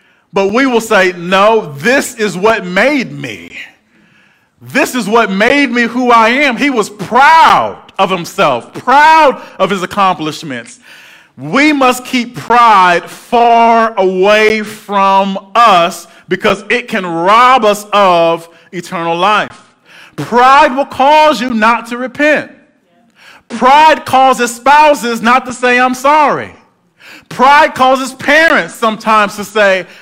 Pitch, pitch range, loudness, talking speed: 230 Hz, 195-265 Hz, -9 LUFS, 130 wpm